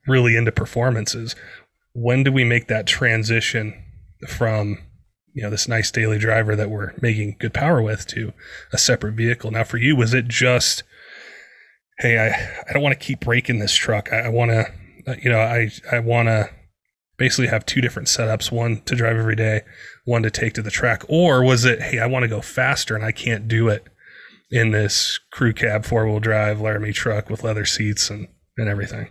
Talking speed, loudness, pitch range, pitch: 200 wpm, -19 LUFS, 110-120 Hz, 115 Hz